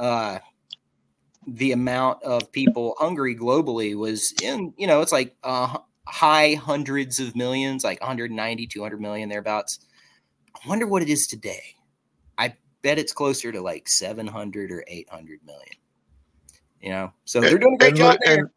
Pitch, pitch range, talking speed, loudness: 120 Hz, 105-135 Hz, 155 wpm, -22 LUFS